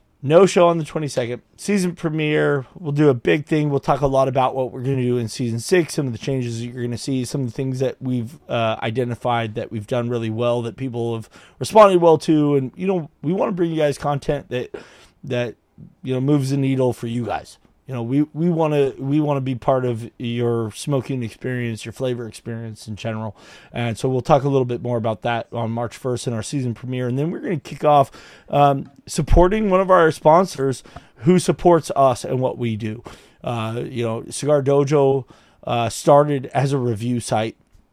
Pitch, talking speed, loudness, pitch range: 130 Hz, 220 wpm, -20 LUFS, 120-150 Hz